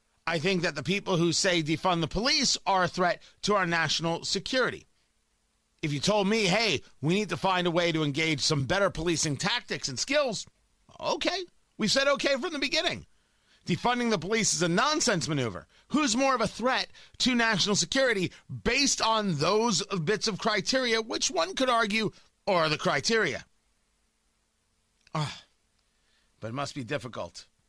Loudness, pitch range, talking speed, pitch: -27 LUFS, 160-225 Hz, 165 wpm, 190 Hz